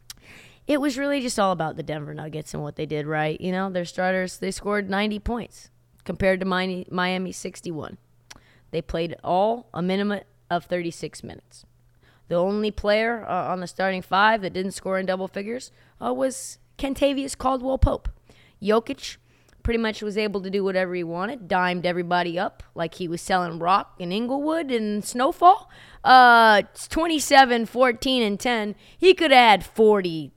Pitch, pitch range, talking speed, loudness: 190 Hz, 175-230 Hz, 170 wpm, -22 LUFS